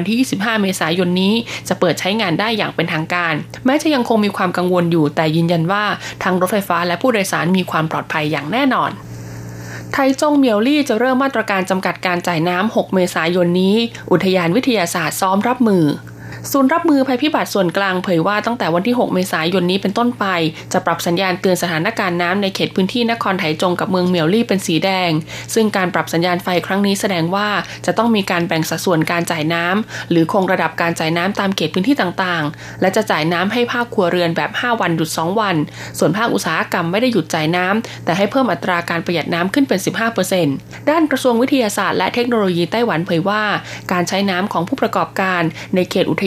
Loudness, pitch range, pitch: -16 LUFS, 170-215 Hz, 185 Hz